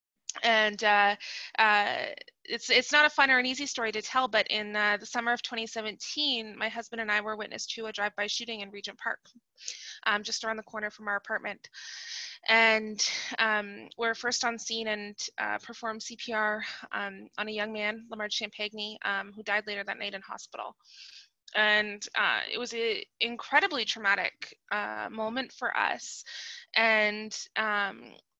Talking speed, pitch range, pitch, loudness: 170 wpm, 210-235 Hz, 220 Hz, -29 LUFS